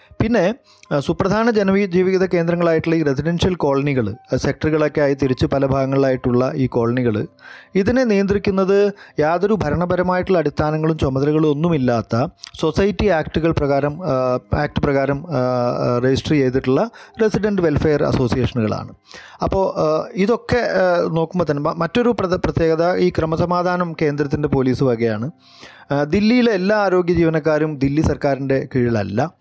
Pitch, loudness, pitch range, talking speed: 155 Hz, -18 LUFS, 135-180 Hz, 105 wpm